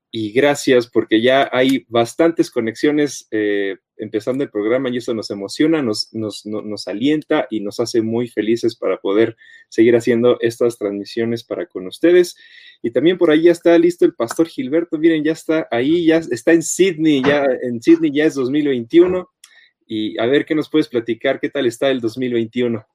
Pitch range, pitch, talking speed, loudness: 115-165 Hz, 140 Hz, 185 wpm, -17 LUFS